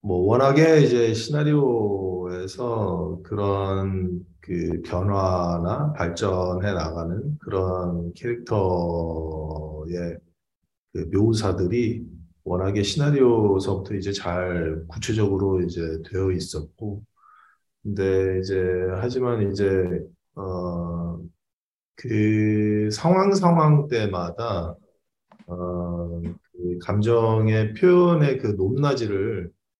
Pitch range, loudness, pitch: 90-110 Hz, -23 LUFS, 95 Hz